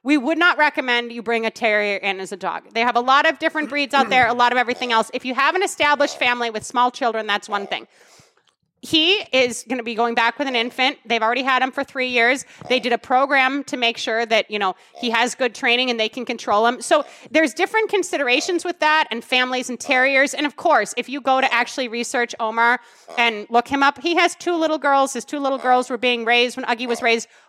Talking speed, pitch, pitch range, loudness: 245 wpm, 250 Hz, 235-280 Hz, -19 LUFS